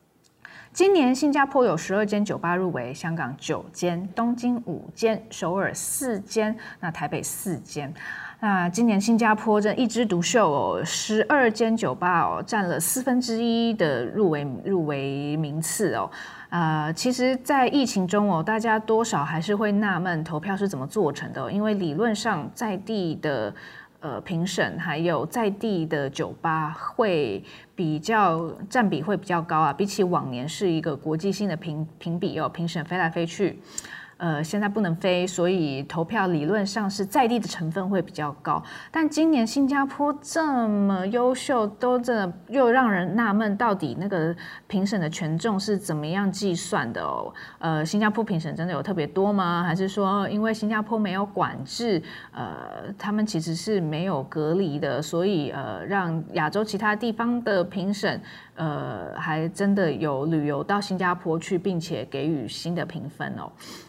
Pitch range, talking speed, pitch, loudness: 165-215 Hz, 245 characters per minute, 195 Hz, -25 LUFS